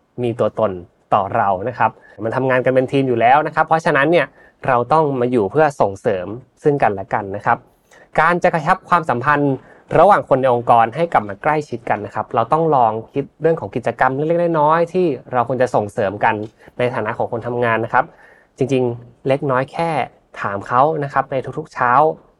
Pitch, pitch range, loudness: 130 Hz, 120-155 Hz, -17 LUFS